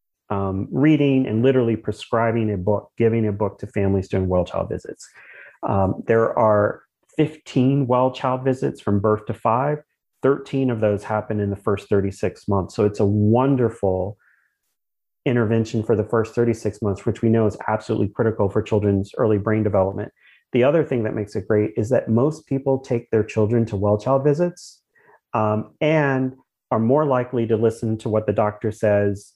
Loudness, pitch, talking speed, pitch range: -21 LUFS, 110 Hz, 170 wpm, 105-125 Hz